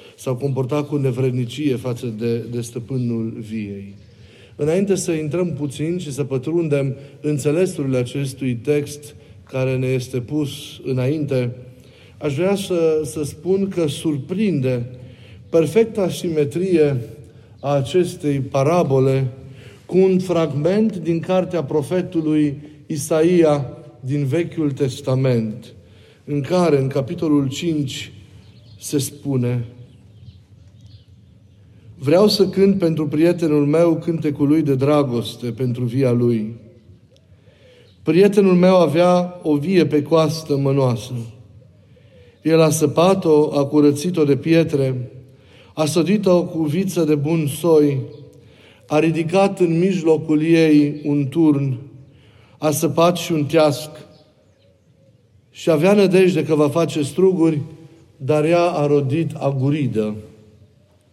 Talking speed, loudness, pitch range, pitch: 110 wpm, -19 LUFS, 125-160 Hz, 145 Hz